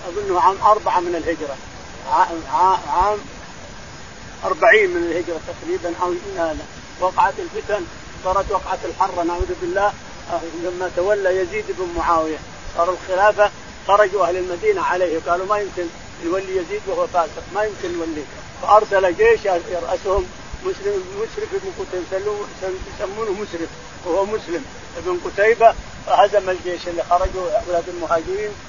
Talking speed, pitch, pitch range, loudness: 125 wpm, 185 Hz, 175-215 Hz, -20 LUFS